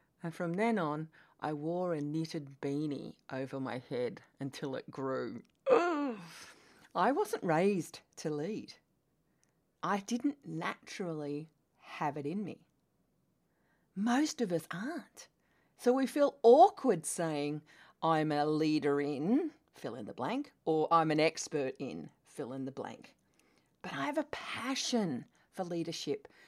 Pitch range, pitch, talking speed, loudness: 150-240 Hz, 170 Hz, 140 wpm, -34 LUFS